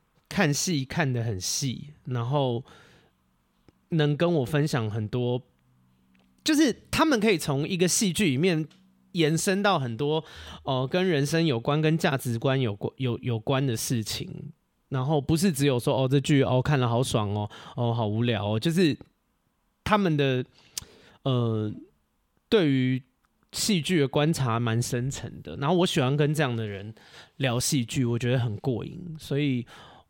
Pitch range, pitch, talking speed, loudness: 120-160 Hz, 135 Hz, 220 characters per minute, -26 LUFS